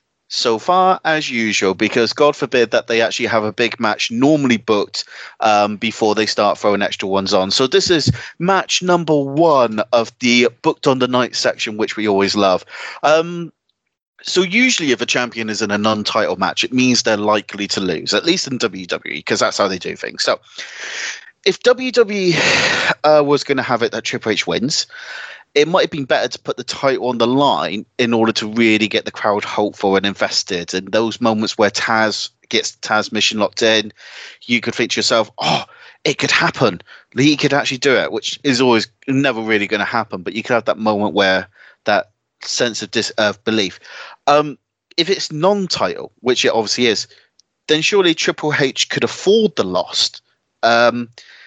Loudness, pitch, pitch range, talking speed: -16 LUFS, 125 Hz, 110-160 Hz, 190 wpm